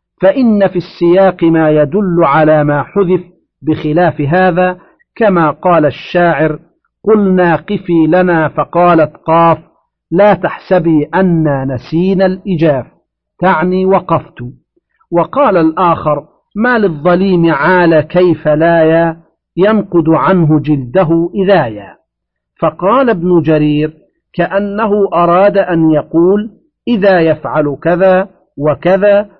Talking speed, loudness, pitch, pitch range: 95 wpm, -11 LUFS, 175 Hz, 155-190 Hz